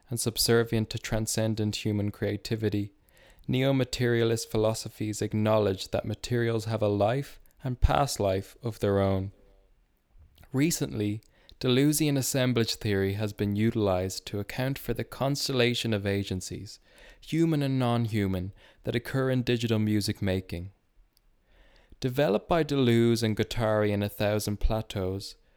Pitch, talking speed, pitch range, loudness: 110 Hz, 125 wpm, 100-120 Hz, -28 LUFS